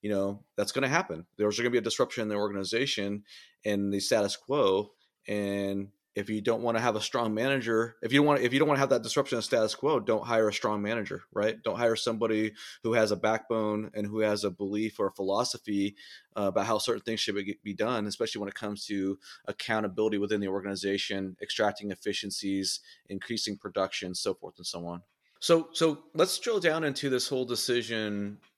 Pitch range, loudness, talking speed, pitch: 100-115 Hz, -30 LUFS, 210 wpm, 105 Hz